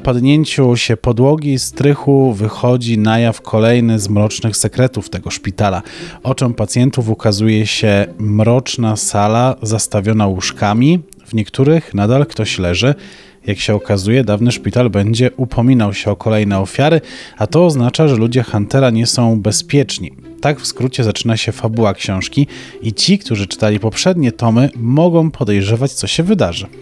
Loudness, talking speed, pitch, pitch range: -14 LUFS, 145 wpm, 115 Hz, 105-130 Hz